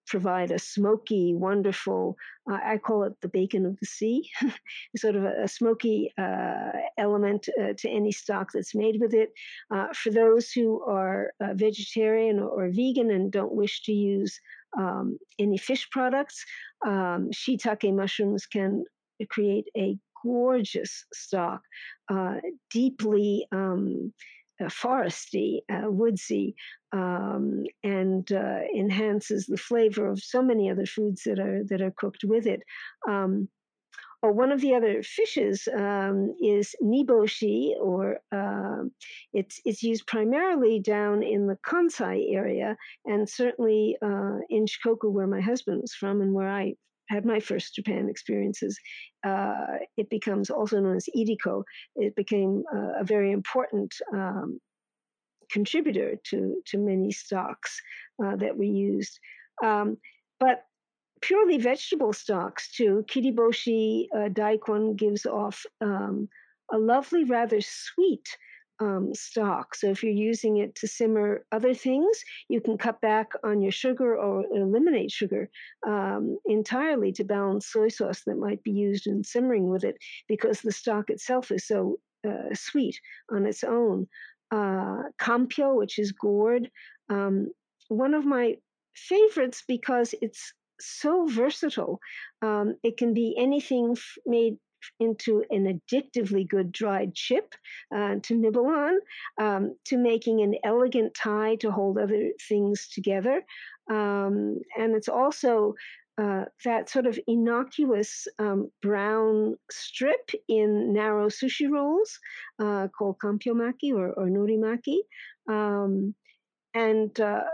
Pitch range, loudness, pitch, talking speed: 200-240 Hz, -27 LUFS, 215 Hz, 140 wpm